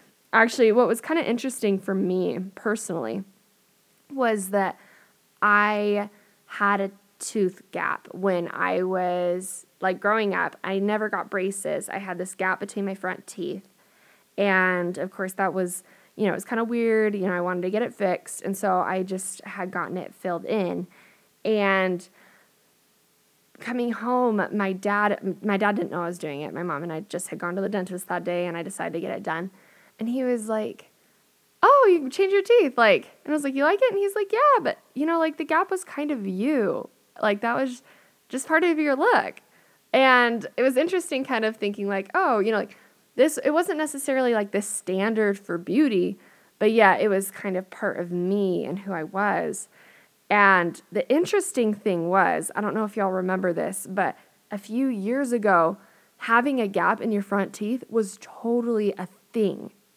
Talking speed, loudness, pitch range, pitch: 195 wpm, -24 LUFS, 185-235 Hz, 205 Hz